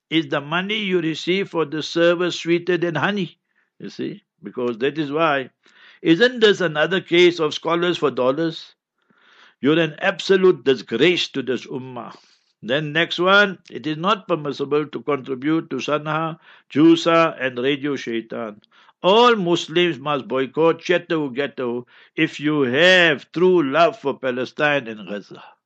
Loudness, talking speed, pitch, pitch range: -19 LUFS, 145 wpm, 160 Hz, 140-175 Hz